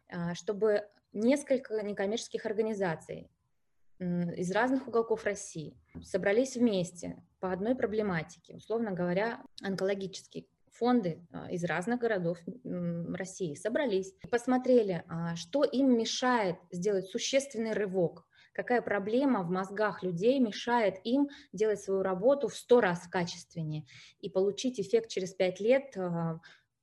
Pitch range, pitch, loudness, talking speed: 180-235 Hz, 200 Hz, -32 LUFS, 110 wpm